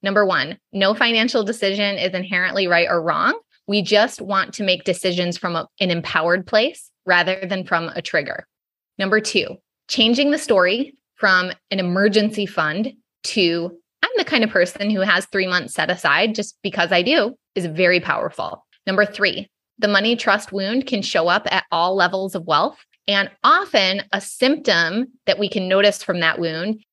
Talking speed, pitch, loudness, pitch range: 175 wpm, 195 Hz, -19 LUFS, 180-215 Hz